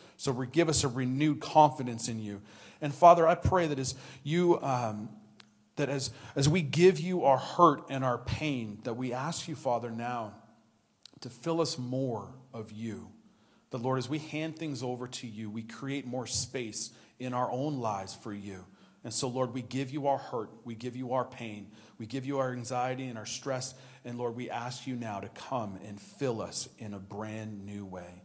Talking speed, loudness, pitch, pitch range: 200 wpm, -31 LUFS, 125 Hz, 115-140 Hz